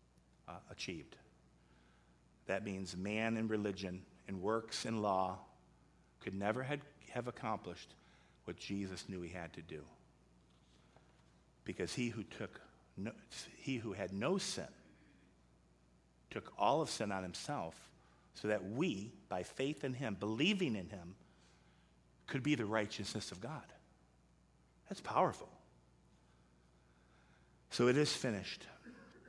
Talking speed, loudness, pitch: 120 wpm, -41 LUFS, 85 Hz